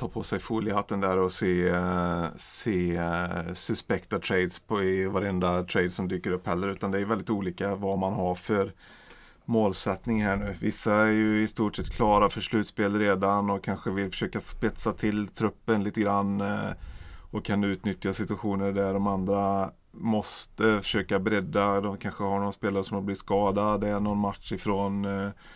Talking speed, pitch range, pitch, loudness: 170 wpm, 95-105 Hz, 100 Hz, -28 LUFS